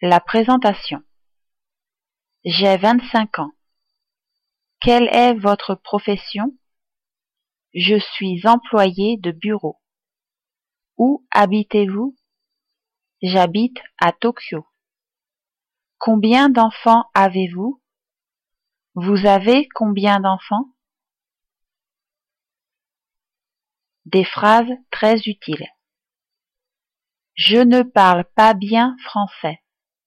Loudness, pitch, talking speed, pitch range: -16 LUFS, 215 Hz, 70 wpm, 195-240 Hz